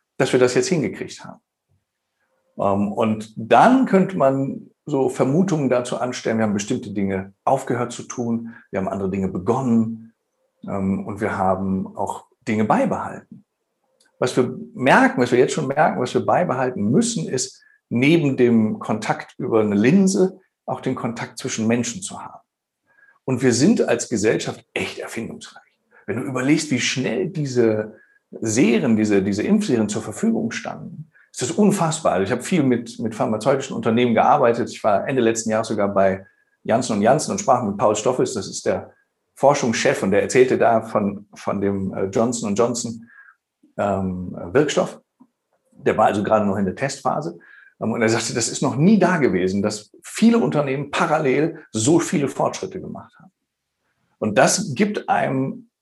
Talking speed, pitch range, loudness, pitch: 160 wpm, 105-155 Hz, -20 LUFS, 125 Hz